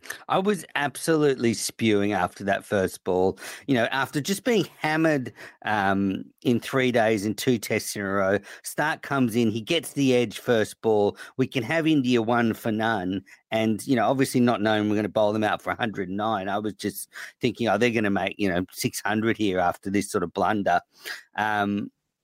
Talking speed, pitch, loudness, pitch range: 195 wpm, 115 Hz, -25 LUFS, 100-130 Hz